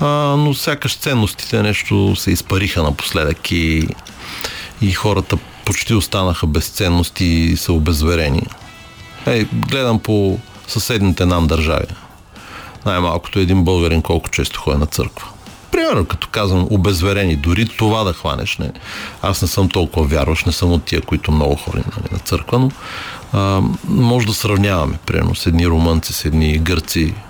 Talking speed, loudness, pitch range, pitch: 145 wpm, -16 LUFS, 85-105 Hz, 95 Hz